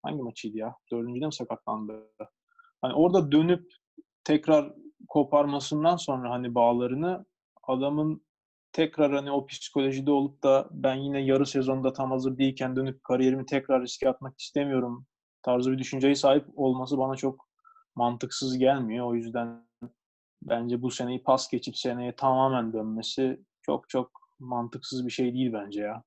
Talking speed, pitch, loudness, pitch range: 140 wpm, 130 Hz, -28 LUFS, 125-140 Hz